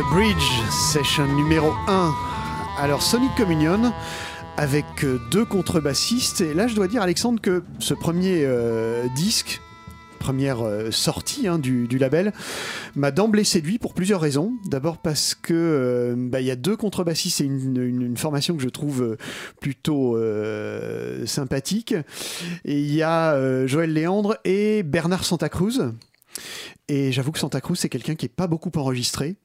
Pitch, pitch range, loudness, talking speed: 150 Hz, 130-180 Hz, -22 LUFS, 155 wpm